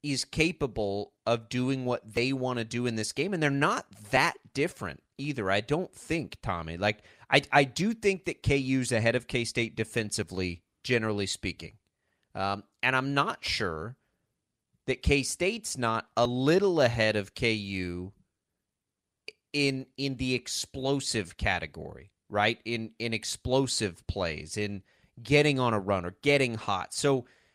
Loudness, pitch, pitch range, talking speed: -29 LUFS, 120 Hz, 105-135 Hz, 150 wpm